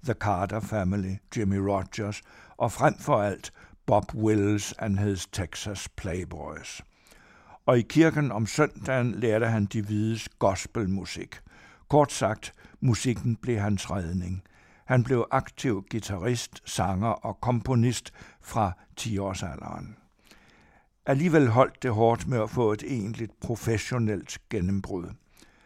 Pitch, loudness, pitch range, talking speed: 110 Hz, -27 LUFS, 100-120 Hz, 120 wpm